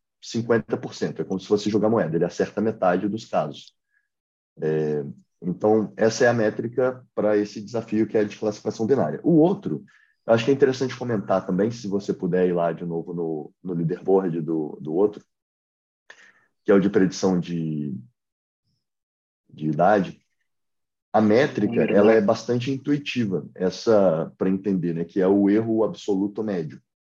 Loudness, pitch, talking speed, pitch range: -23 LUFS, 100 Hz, 160 wpm, 85-110 Hz